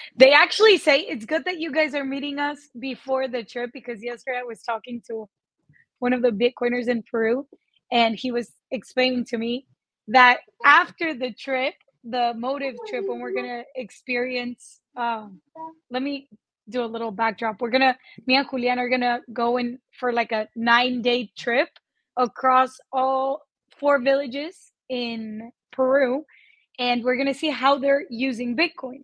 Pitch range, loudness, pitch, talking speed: 235-275 Hz, -23 LUFS, 250 Hz, 170 wpm